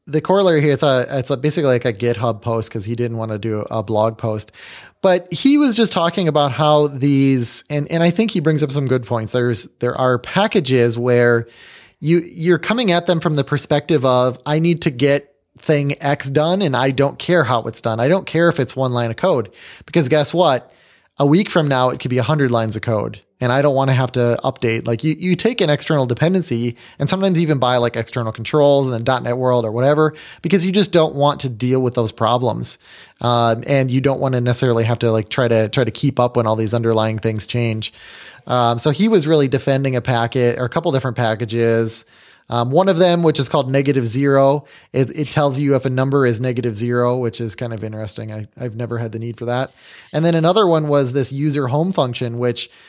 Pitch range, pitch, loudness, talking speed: 120-150 Hz, 130 Hz, -17 LUFS, 235 wpm